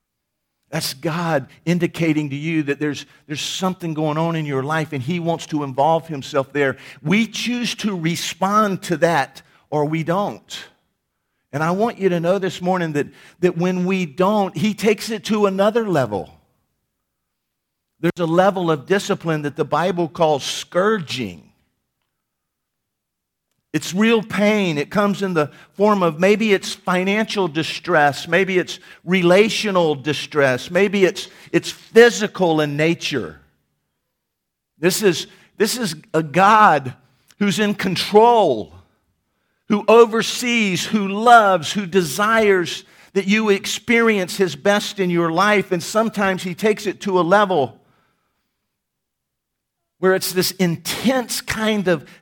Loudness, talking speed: -18 LUFS, 135 wpm